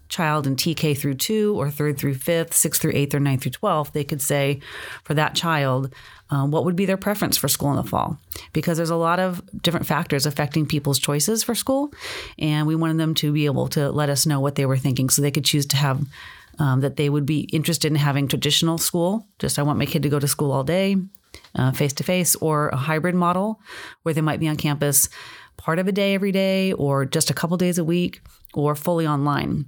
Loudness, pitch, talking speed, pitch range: -21 LUFS, 150 Hz, 235 wpm, 145-170 Hz